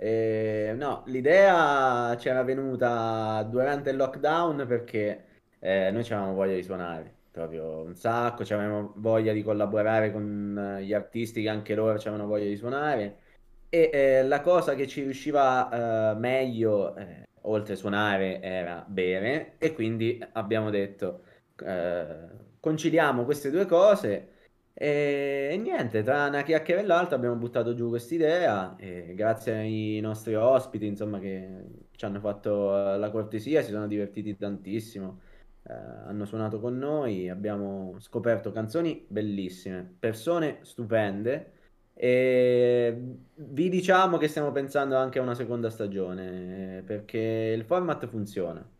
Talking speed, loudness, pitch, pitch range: 135 wpm, -27 LUFS, 110 Hz, 105-130 Hz